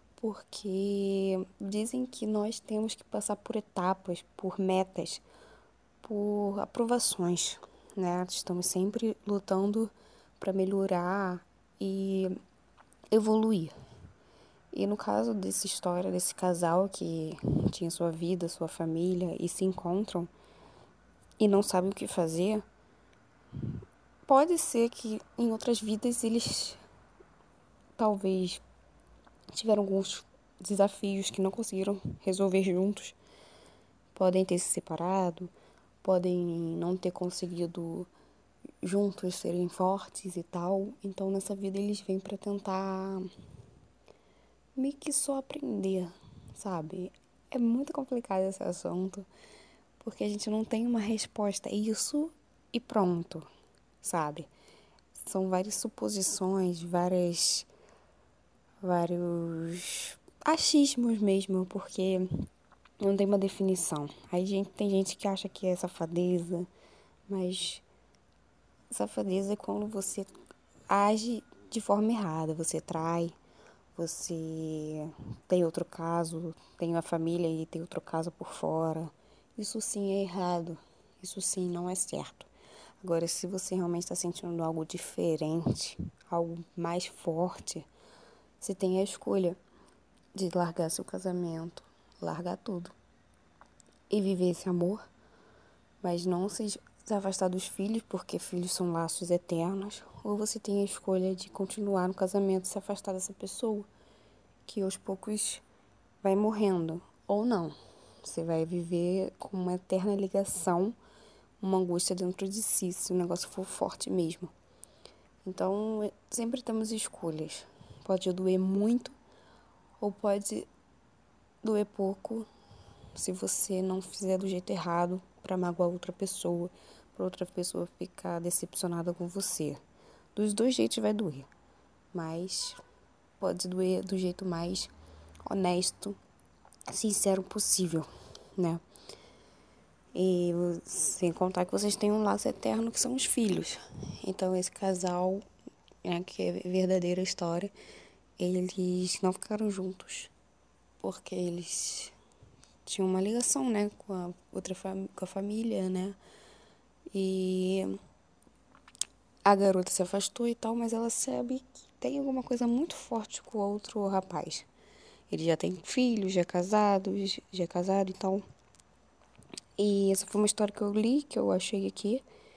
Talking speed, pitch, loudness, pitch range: 125 wpm, 190 Hz, -32 LUFS, 175-205 Hz